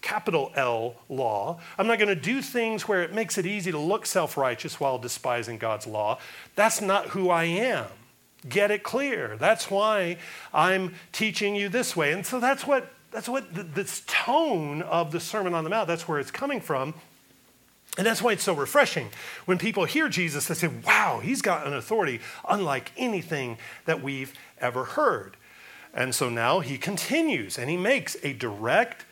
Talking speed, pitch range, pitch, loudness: 185 wpm, 160-225 Hz, 190 Hz, -26 LUFS